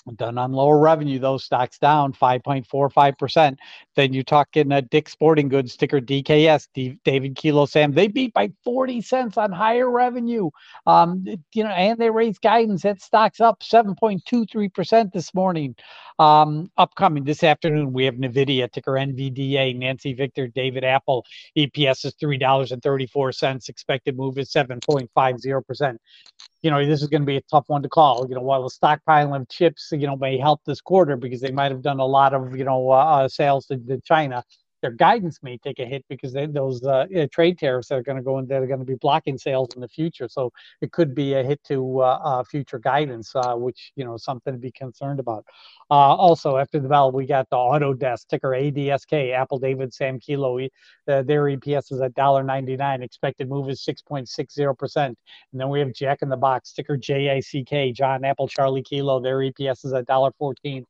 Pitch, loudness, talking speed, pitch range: 140 Hz, -21 LUFS, 200 wpm, 130-150 Hz